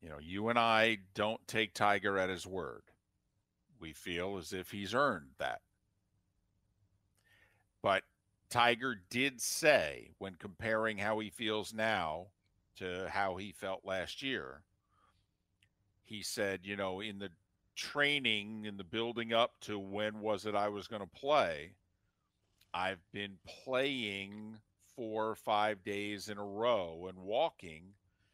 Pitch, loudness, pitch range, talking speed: 100 Hz, -36 LUFS, 95-110 Hz, 140 wpm